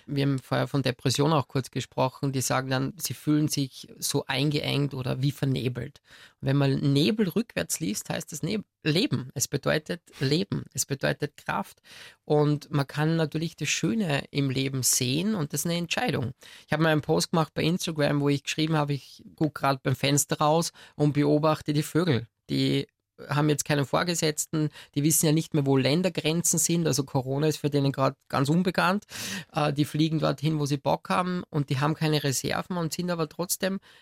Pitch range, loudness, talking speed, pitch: 140-160 Hz, -27 LUFS, 190 wpm, 150 Hz